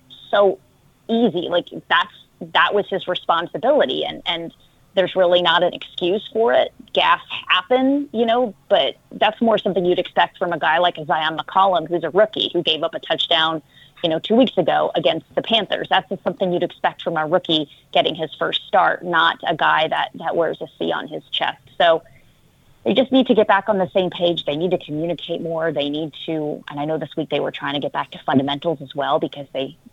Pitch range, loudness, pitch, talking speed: 155-195 Hz, -19 LUFS, 175 Hz, 215 wpm